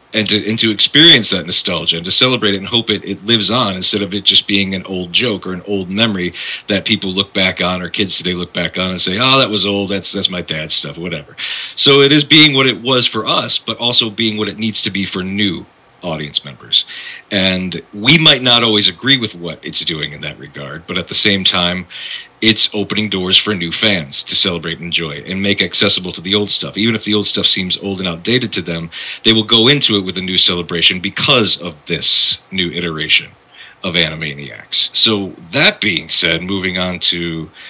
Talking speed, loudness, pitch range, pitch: 230 wpm, -12 LUFS, 90-110 Hz, 100 Hz